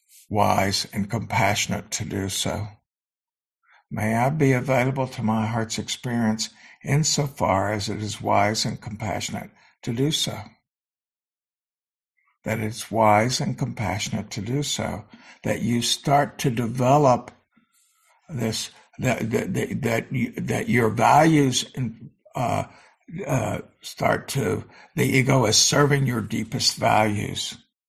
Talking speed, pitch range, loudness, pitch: 125 wpm, 110-135 Hz, -23 LUFS, 115 Hz